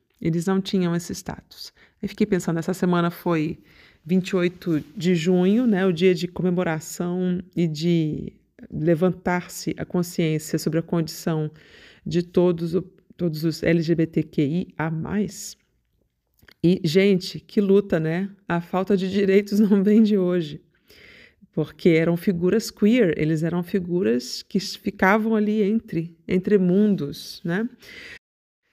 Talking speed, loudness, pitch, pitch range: 125 wpm, -23 LUFS, 180 Hz, 170-200 Hz